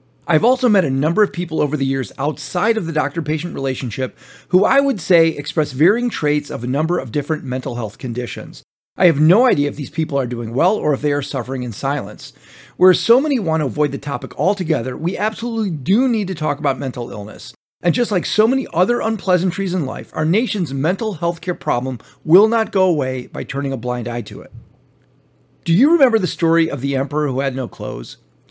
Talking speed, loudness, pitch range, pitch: 220 wpm, -18 LUFS, 130-185 Hz, 150 Hz